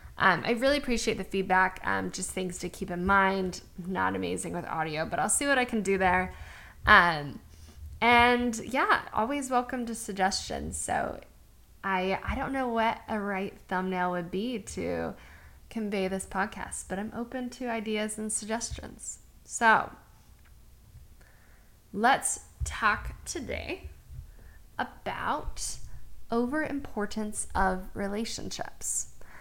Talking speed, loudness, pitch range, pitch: 130 wpm, -29 LUFS, 180-230 Hz, 195 Hz